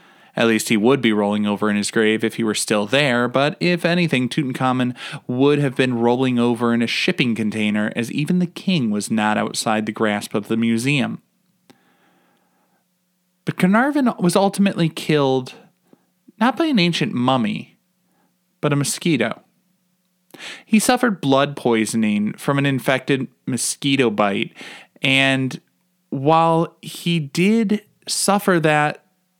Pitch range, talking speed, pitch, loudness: 120-180 Hz, 140 wpm, 145 Hz, -19 LUFS